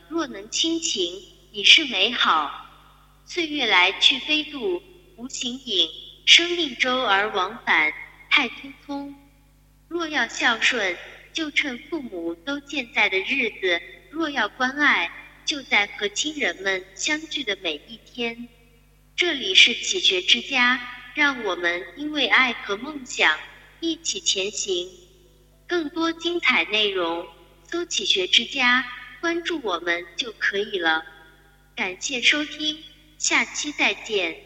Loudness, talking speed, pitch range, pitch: -21 LUFS, 180 characters per minute, 195-325 Hz, 260 Hz